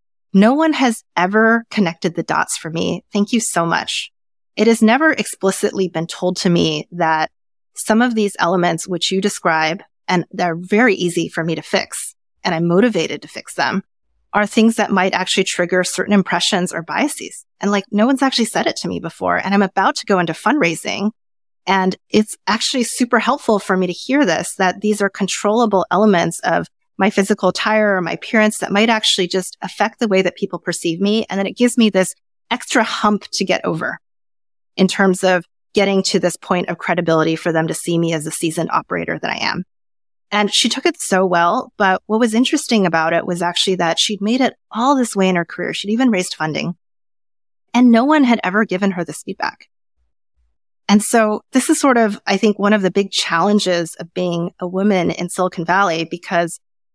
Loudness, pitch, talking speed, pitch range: -17 LUFS, 190 Hz, 205 wpm, 175-215 Hz